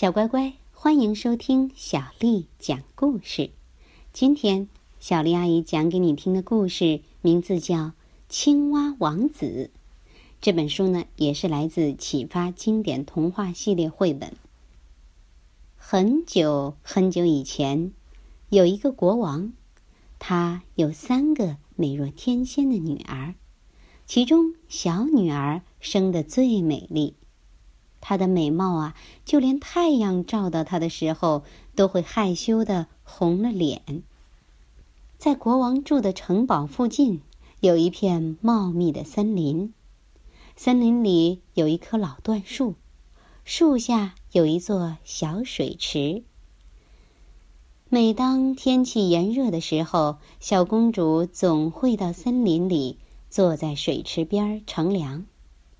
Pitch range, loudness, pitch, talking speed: 160-230 Hz, -23 LUFS, 180 Hz, 175 characters per minute